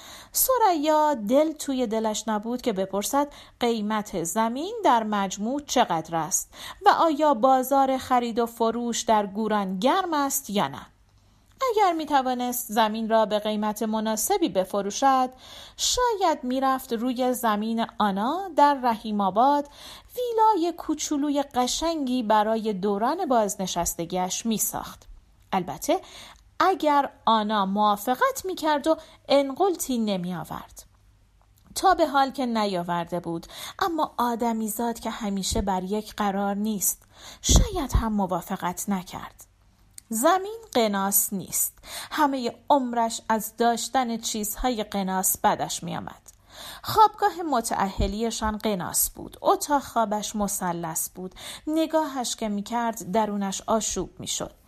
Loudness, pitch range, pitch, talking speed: -25 LUFS, 205-285 Hz, 230 Hz, 115 wpm